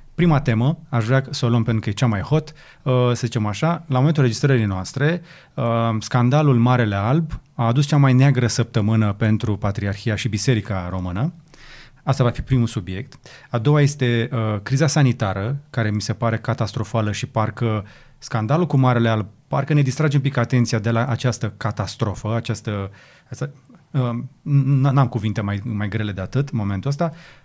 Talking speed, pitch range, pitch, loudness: 175 wpm, 110-140 Hz, 120 Hz, -20 LUFS